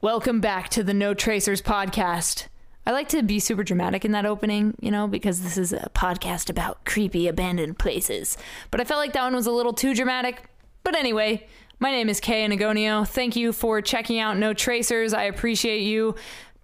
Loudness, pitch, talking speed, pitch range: -24 LUFS, 215 Hz, 200 wpm, 205-235 Hz